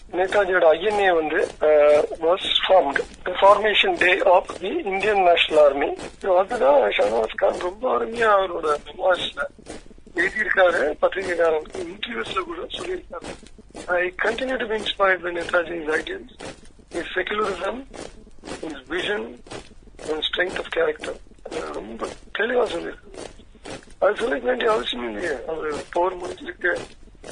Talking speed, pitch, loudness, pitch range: 80 wpm, 195 Hz, -21 LUFS, 175-245 Hz